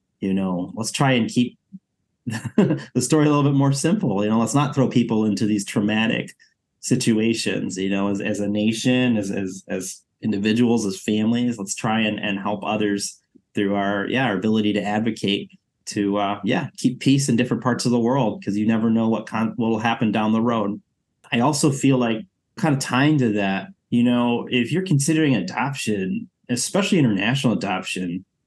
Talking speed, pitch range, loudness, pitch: 190 wpm, 105-130 Hz, -21 LUFS, 115 Hz